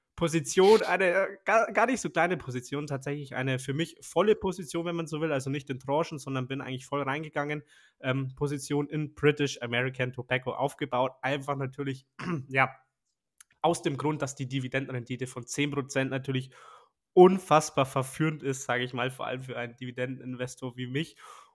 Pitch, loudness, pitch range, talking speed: 135 Hz, -29 LUFS, 130-150 Hz, 165 wpm